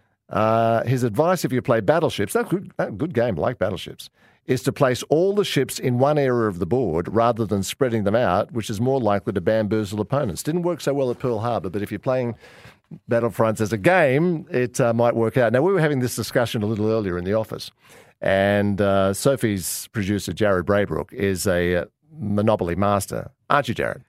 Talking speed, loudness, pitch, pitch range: 210 wpm, -22 LUFS, 115 Hz, 105-130 Hz